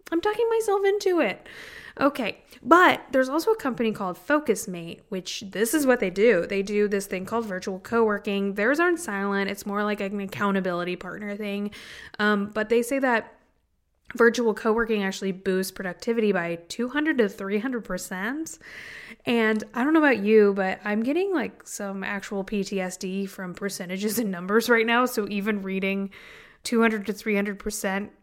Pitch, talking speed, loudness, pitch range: 210 Hz, 170 wpm, -25 LUFS, 195-240 Hz